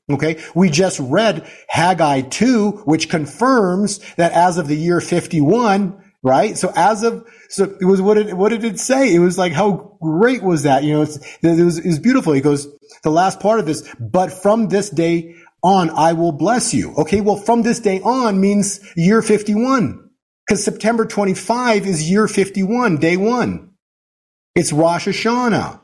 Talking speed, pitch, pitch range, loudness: 180 wpm, 190 Hz, 165-210 Hz, -16 LUFS